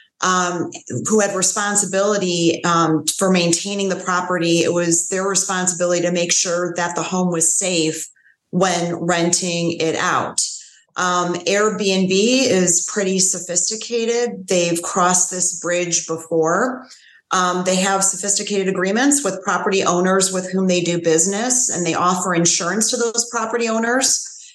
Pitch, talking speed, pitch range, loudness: 185 Hz, 135 wpm, 175-200 Hz, -17 LUFS